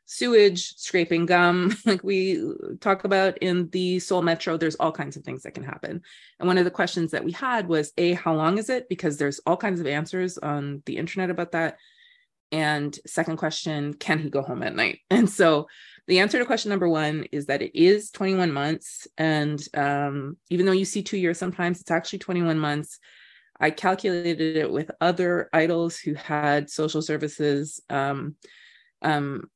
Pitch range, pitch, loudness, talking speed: 155-190 Hz, 170 Hz, -24 LUFS, 185 wpm